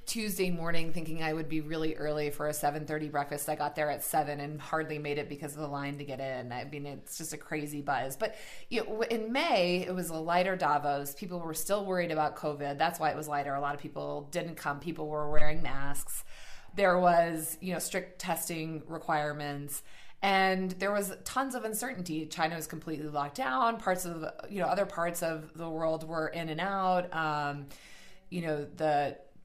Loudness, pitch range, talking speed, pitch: -33 LUFS, 145-175 Hz, 205 wpm, 160 Hz